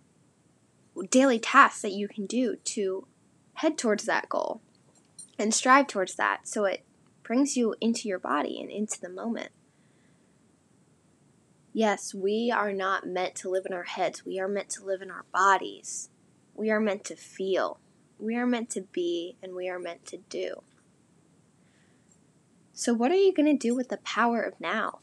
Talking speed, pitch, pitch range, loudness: 175 wpm, 205 Hz, 190-235 Hz, -28 LUFS